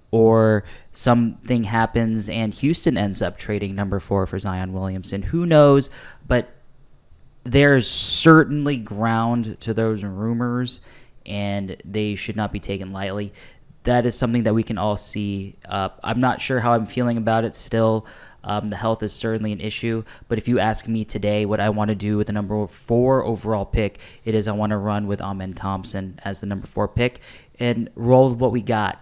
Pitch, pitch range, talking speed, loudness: 110 Hz, 100-120 Hz, 190 wpm, -21 LUFS